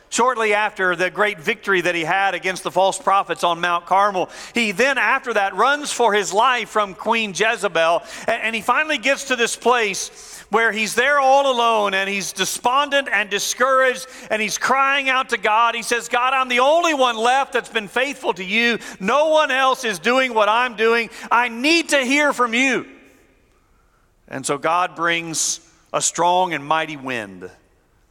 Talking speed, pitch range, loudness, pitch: 180 wpm, 195-255 Hz, -18 LUFS, 225 Hz